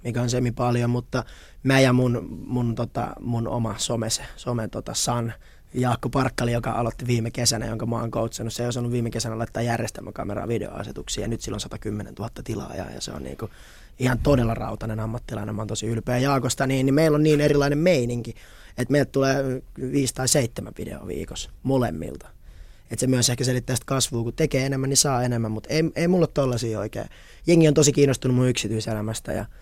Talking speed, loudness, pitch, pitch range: 195 wpm, -24 LUFS, 120 Hz, 110-130 Hz